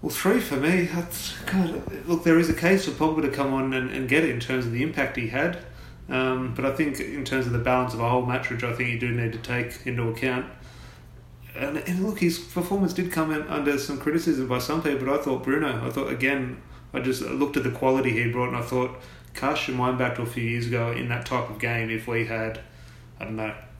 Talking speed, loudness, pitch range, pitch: 255 wpm, -26 LUFS, 120-150 Hz, 130 Hz